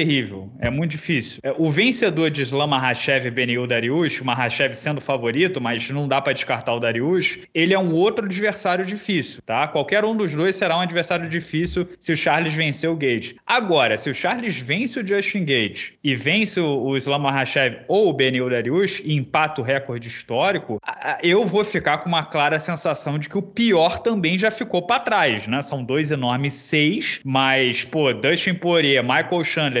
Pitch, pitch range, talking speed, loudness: 155 Hz, 135-180 Hz, 185 wpm, -20 LUFS